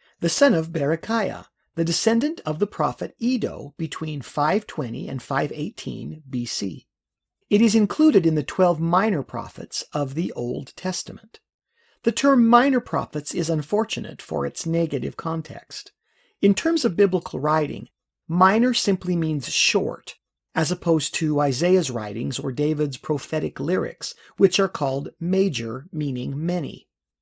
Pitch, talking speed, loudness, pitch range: 170 Hz, 135 wpm, -23 LUFS, 150-215 Hz